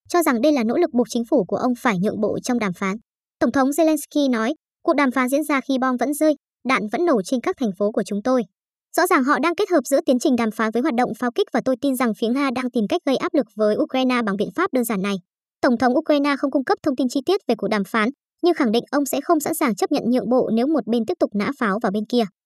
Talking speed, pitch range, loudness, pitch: 300 wpm, 230-300 Hz, -21 LUFS, 260 Hz